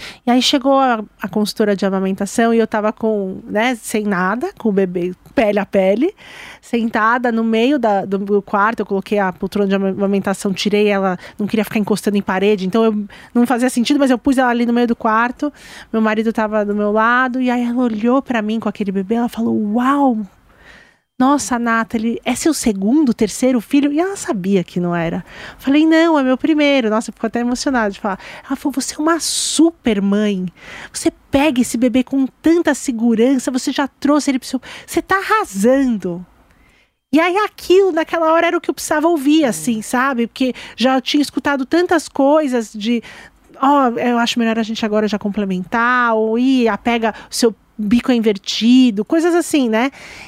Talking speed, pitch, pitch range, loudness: 190 wpm, 235 Hz, 210-275 Hz, -16 LUFS